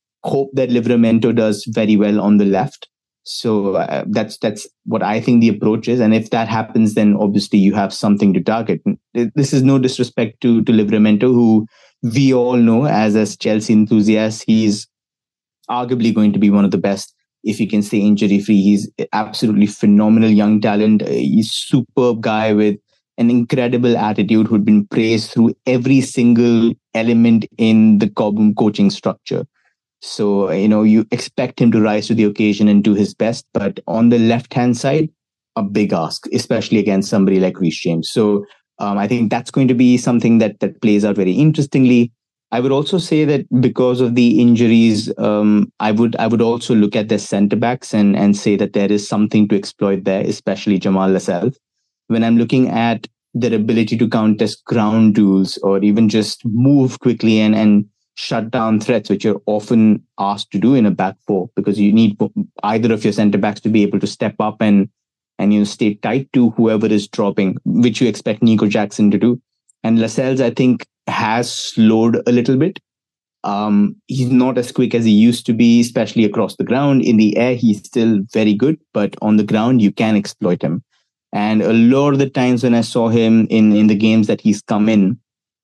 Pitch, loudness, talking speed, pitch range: 110 Hz, -15 LUFS, 195 wpm, 105-120 Hz